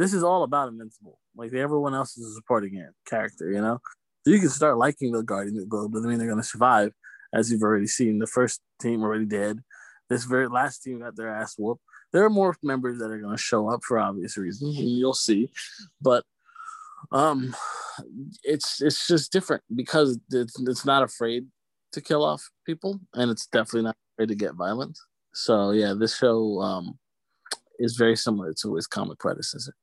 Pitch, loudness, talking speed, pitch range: 120 Hz, -25 LUFS, 195 wpm, 110-140 Hz